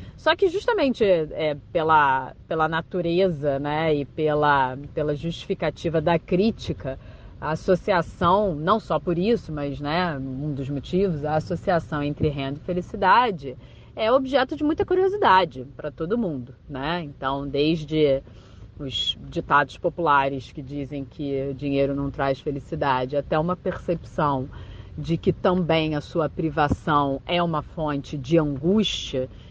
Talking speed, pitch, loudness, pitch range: 135 wpm, 155 Hz, -24 LUFS, 140-175 Hz